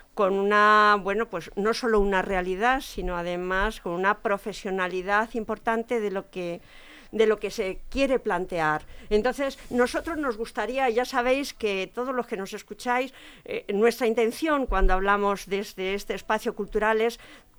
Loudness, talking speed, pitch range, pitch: -26 LUFS, 160 wpm, 195-240 Hz, 215 Hz